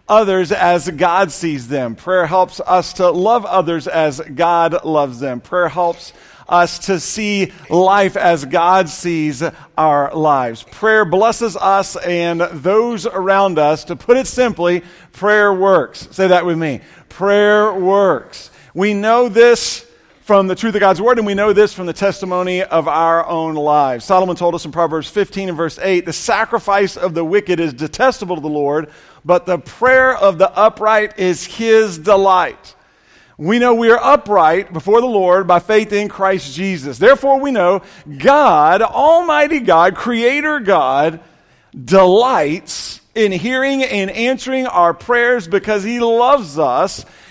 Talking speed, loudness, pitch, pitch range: 160 wpm, -14 LUFS, 190 Hz, 170-215 Hz